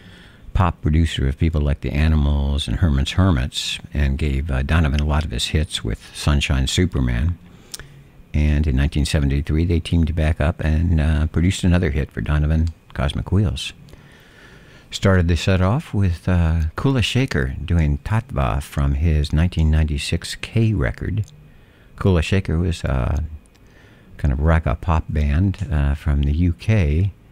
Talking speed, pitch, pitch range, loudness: 145 wpm, 80 Hz, 75-95 Hz, -20 LUFS